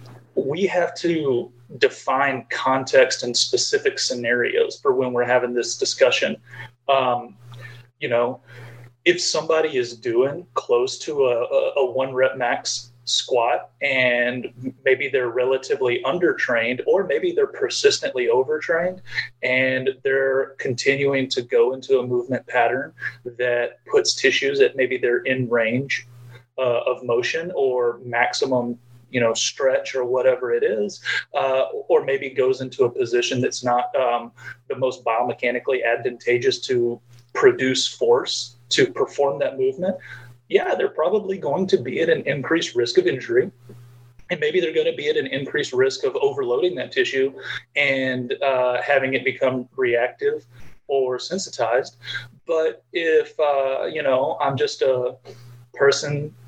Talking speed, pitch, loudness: 140 wpm, 165 Hz, -21 LUFS